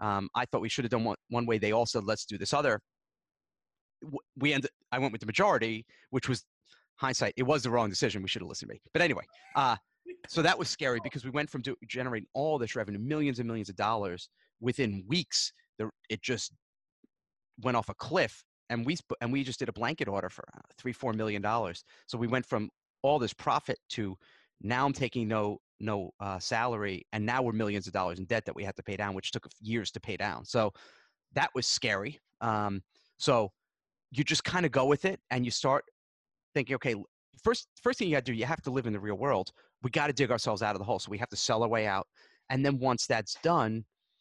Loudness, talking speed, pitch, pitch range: -32 LUFS, 230 wpm, 120 Hz, 105-140 Hz